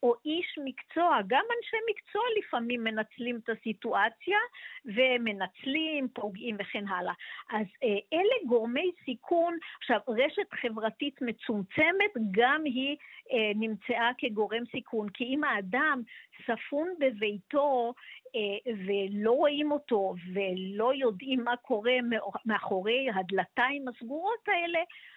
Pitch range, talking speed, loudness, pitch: 220-300 Hz, 105 wpm, -30 LUFS, 245 Hz